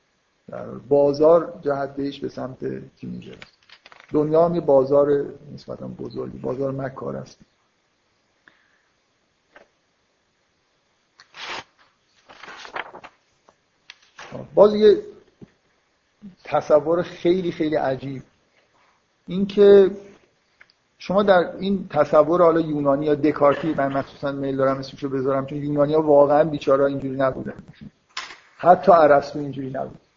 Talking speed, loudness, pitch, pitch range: 95 wpm, -20 LUFS, 145 Hz, 135-170 Hz